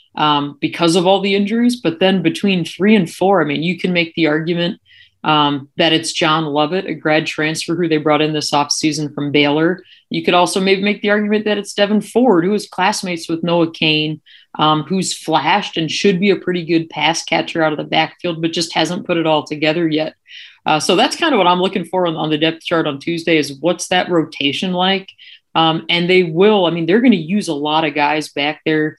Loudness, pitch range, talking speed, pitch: -16 LUFS, 155-190 Hz, 230 wpm, 170 Hz